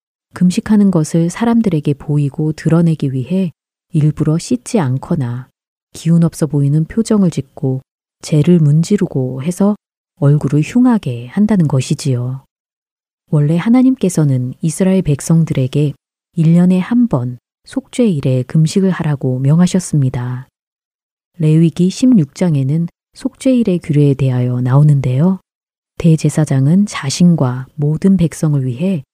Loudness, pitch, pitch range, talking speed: -14 LUFS, 160 Hz, 140-185 Hz, 275 characters per minute